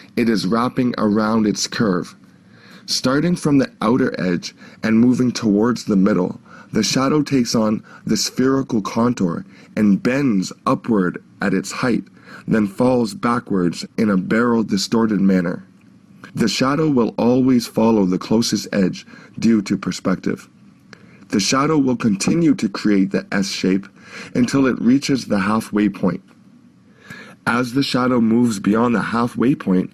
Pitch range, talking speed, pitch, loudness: 105-125 Hz, 140 wpm, 115 Hz, -18 LUFS